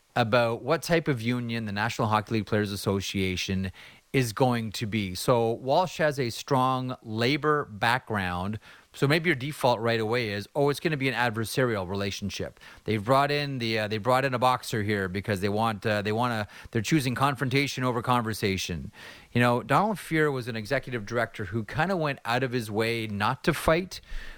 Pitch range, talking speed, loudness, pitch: 105-135 Hz, 195 wpm, -27 LUFS, 120 Hz